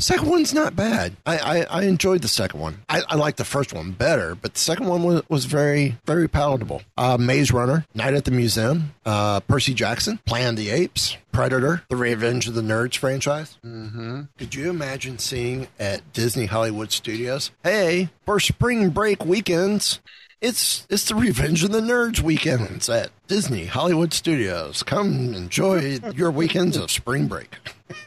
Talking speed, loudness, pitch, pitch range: 170 wpm, -22 LUFS, 140 Hz, 120-170 Hz